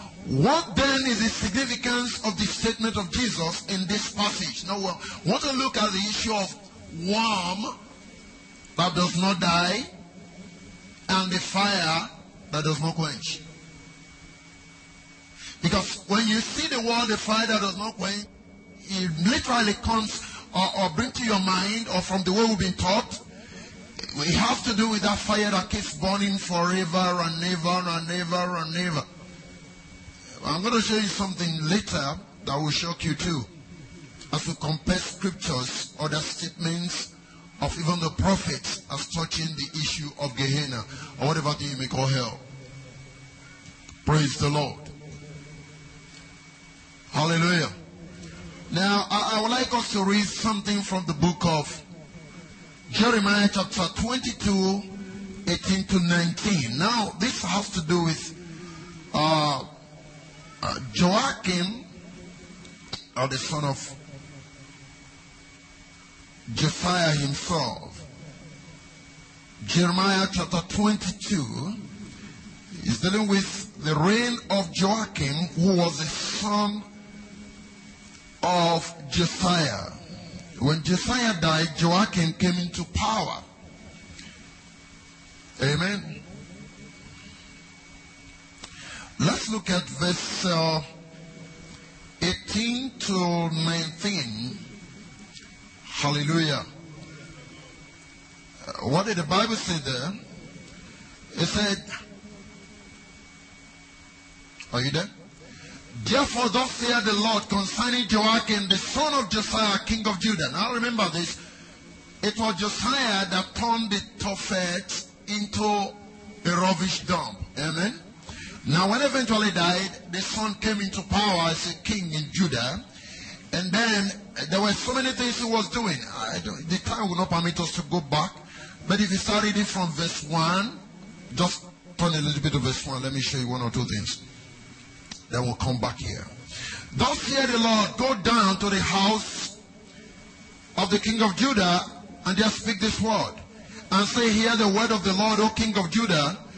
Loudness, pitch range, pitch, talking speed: -25 LUFS, 155-210 Hz, 180 Hz, 135 wpm